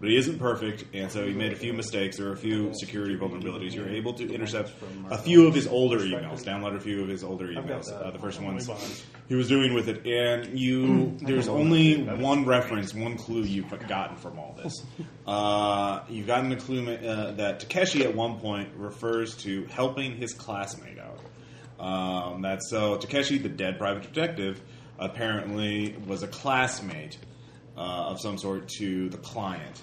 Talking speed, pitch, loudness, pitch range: 190 wpm, 110 Hz, -28 LUFS, 100-125 Hz